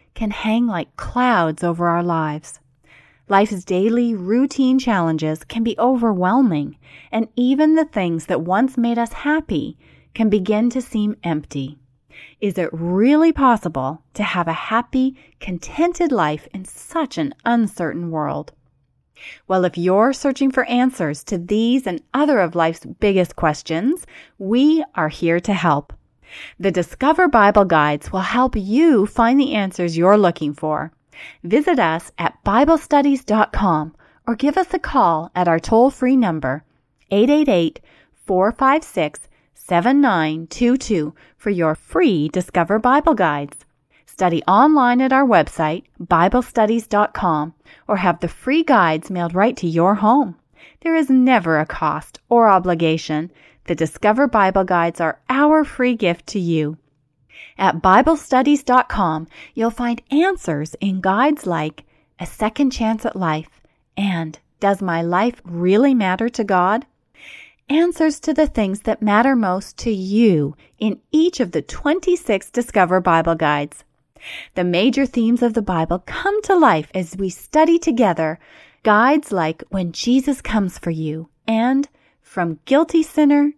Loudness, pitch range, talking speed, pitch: -18 LUFS, 165-255 Hz, 140 wpm, 205 Hz